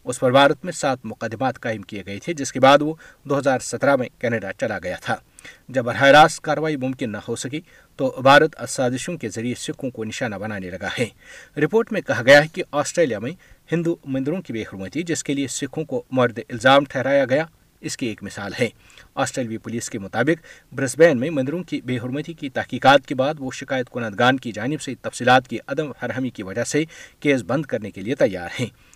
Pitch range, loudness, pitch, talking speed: 120-155 Hz, -21 LUFS, 135 Hz, 210 wpm